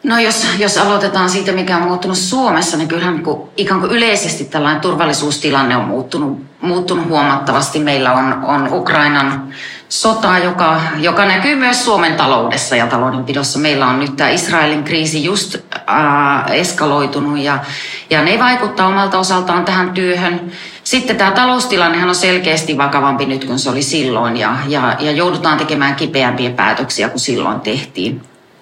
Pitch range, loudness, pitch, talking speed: 140-185 Hz, -13 LUFS, 160 Hz, 150 wpm